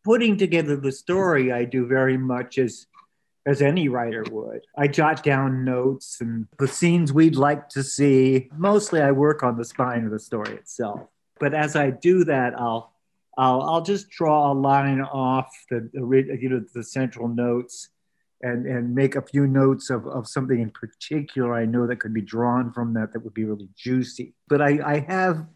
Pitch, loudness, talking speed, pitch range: 130 Hz, -22 LUFS, 190 wpm, 120-145 Hz